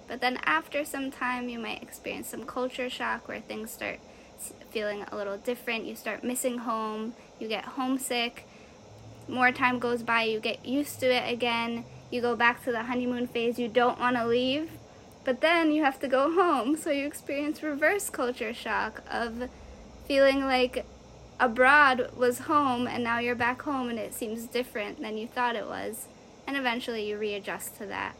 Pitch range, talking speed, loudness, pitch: 235-270 Hz, 185 wpm, -28 LUFS, 245 Hz